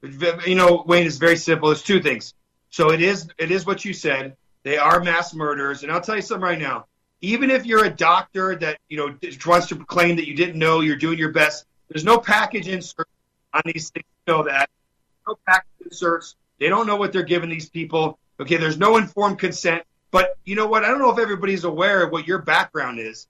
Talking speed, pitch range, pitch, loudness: 230 wpm, 155-190 Hz, 170 Hz, -20 LUFS